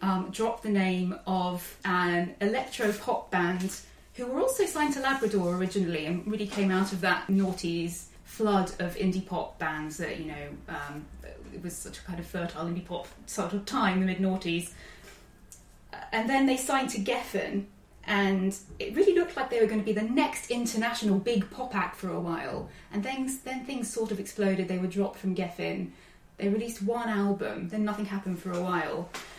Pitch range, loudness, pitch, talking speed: 180-225 Hz, -30 LUFS, 195 Hz, 190 wpm